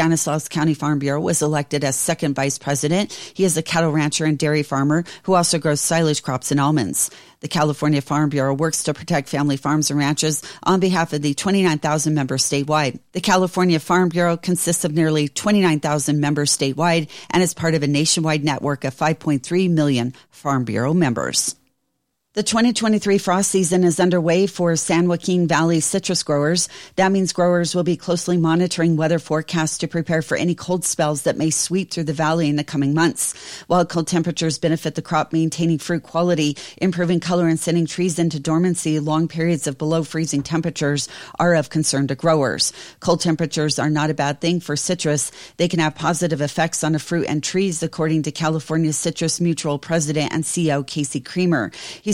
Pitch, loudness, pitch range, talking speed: 160 Hz, -19 LUFS, 150-175 Hz, 185 wpm